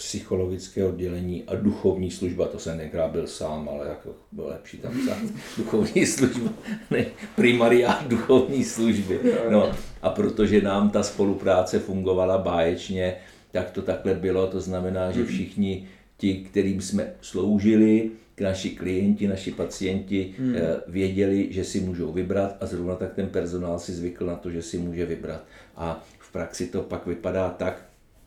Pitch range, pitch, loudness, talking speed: 90-105 Hz, 95 Hz, -25 LUFS, 150 wpm